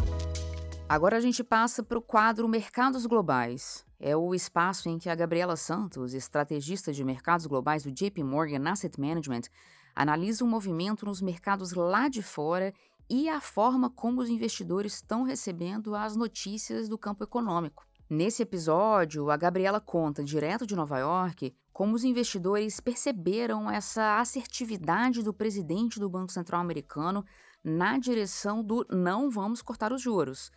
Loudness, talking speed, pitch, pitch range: -30 LUFS, 150 wpm, 195 Hz, 160-225 Hz